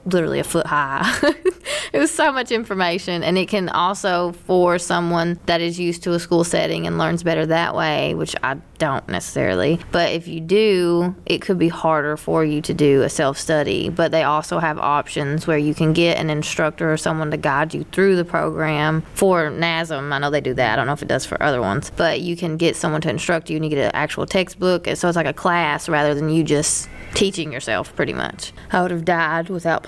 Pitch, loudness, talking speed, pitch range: 165 Hz, -19 LUFS, 225 wpm, 155-180 Hz